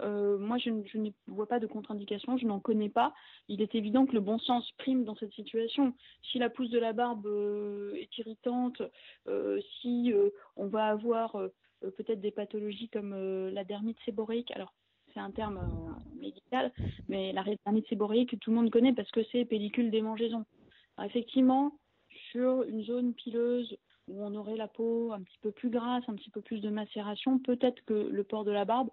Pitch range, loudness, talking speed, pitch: 210-240 Hz, -33 LUFS, 200 wpm, 225 Hz